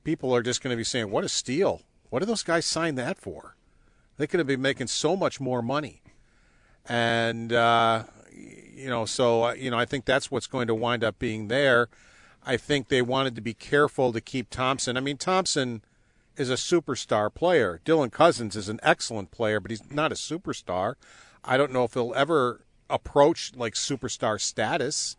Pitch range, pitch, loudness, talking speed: 115-140 Hz, 125 Hz, -26 LUFS, 195 wpm